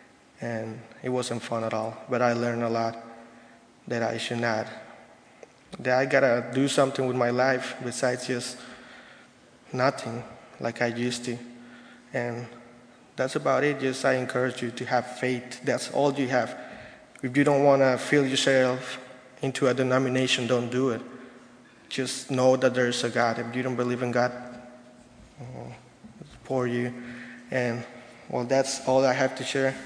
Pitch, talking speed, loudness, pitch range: 125 Hz, 165 wpm, -26 LUFS, 120-130 Hz